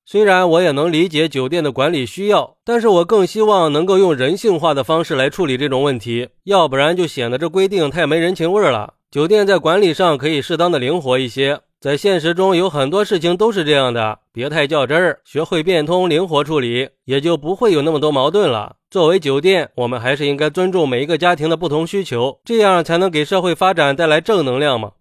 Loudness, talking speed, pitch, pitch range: -15 LUFS, 340 characters per minute, 165 Hz, 140-185 Hz